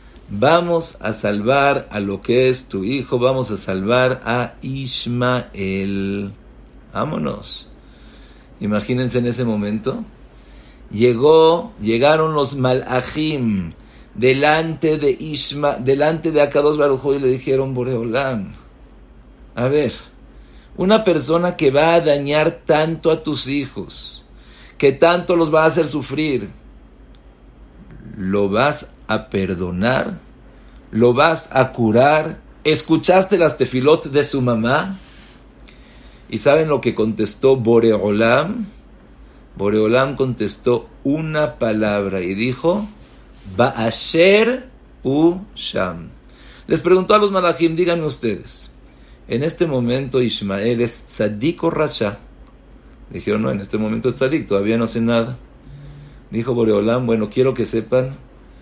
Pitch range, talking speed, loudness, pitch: 115-155 Hz, 120 wpm, -18 LUFS, 130 Hz